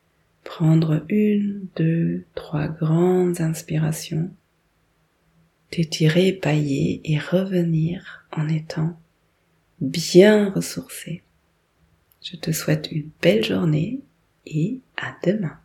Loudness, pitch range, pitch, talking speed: -22 LUFS, 155-180 Hz, 165 Hz, 90 wpm